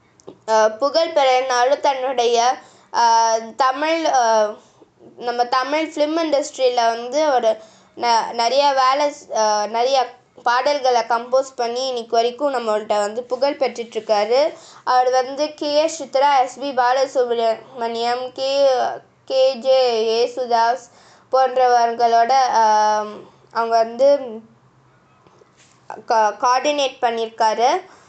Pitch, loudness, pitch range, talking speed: 250 Hz, -18 LUFS, 230-270 Hz, 85 wpm